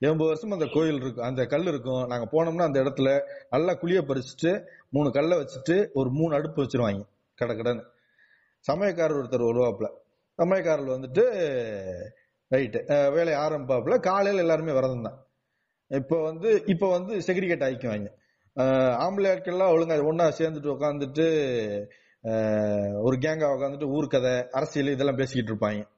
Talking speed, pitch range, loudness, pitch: 125 wpm, 130-165 Hz, -26 LUFS, 145 Hz